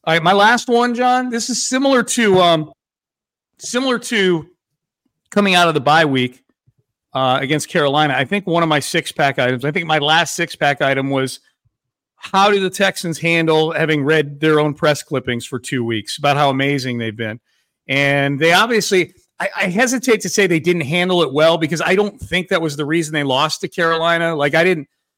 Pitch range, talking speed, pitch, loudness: 140-185 Hz, 205 wpm, 160 Hz, -16 LUFS